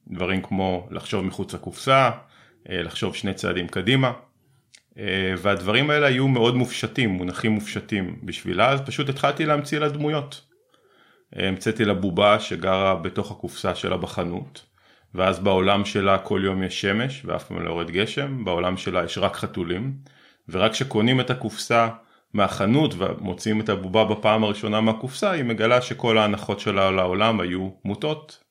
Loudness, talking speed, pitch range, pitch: -23 LUFS, 140 wpm, 95-125 Hz, 110 Hz